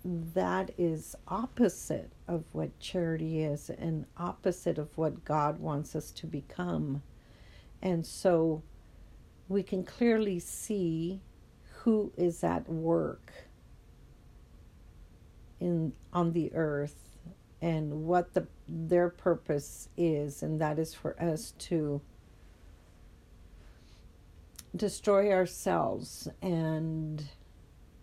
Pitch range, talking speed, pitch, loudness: 145-175 Hz, 95 wpm, 160 Hz, -33 LUFS